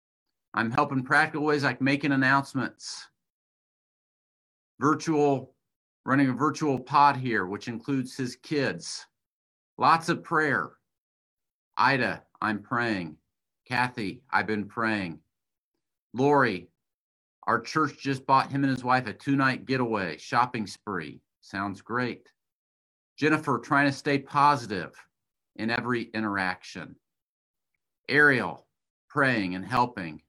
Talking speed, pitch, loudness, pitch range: 110 wpm, 125 Hz, -26 LUFS, 100-140 Hz